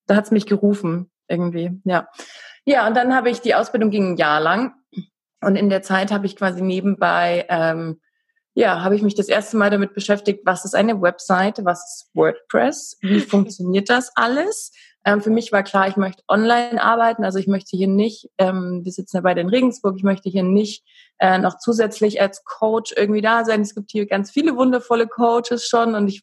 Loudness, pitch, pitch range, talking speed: -19 LUFS, 205 Hz, 190-230 Hz, 205 wpm